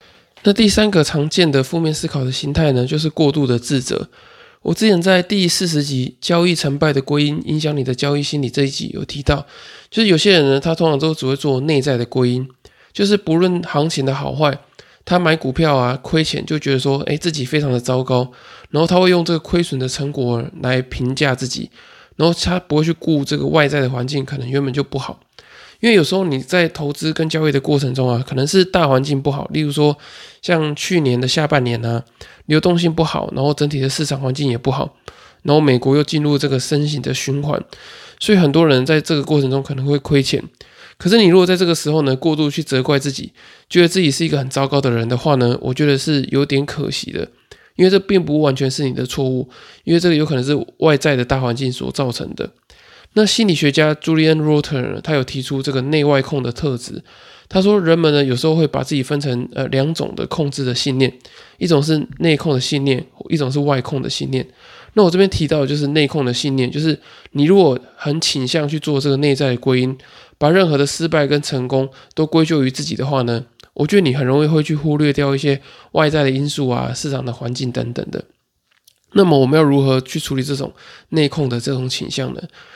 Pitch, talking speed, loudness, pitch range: 145 Hz, 330 characters per minute, -17 LUFS, 135-160 Hz